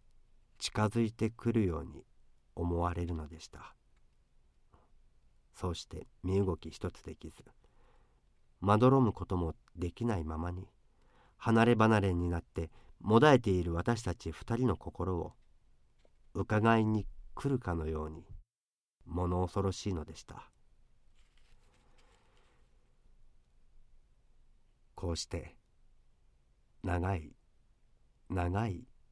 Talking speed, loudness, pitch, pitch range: 195 characters per minute, -33 LUFS, 90 Hz, 85-110 Hz